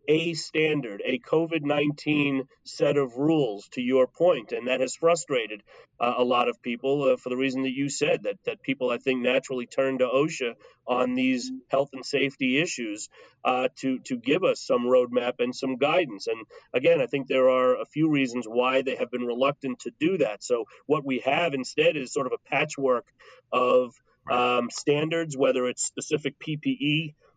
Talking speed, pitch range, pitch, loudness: 185 wpm, 125-160 Hz, 135 Hz, -26 LUFS